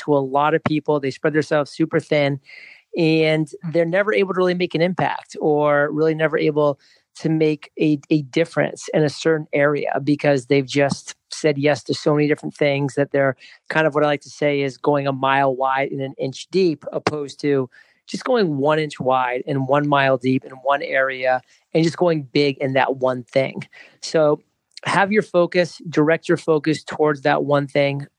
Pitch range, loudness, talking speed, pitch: 140-160 Hz, -20 LUFS, 200 wpm, 150 Hz